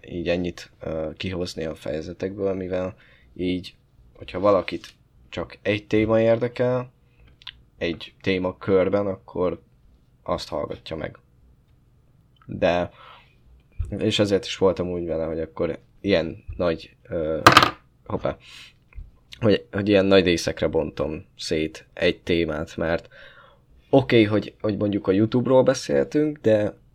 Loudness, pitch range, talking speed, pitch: -23 LUFS, 85-110 Hz, 120 wpm, 95 Hz